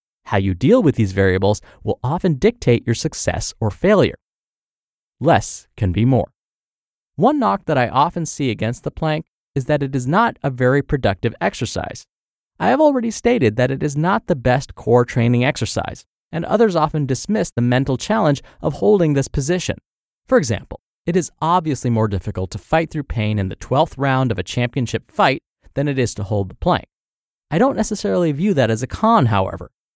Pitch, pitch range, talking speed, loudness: 130 Hz, 110-160 Hz, 190 wpm, -19 LUFS